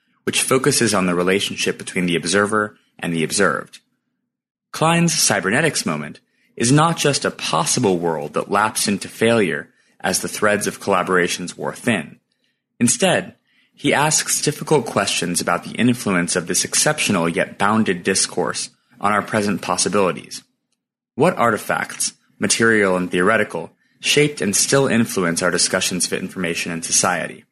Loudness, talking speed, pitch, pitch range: -18 LUFS, 140 wpm, 105 Hz, 90-140 Hz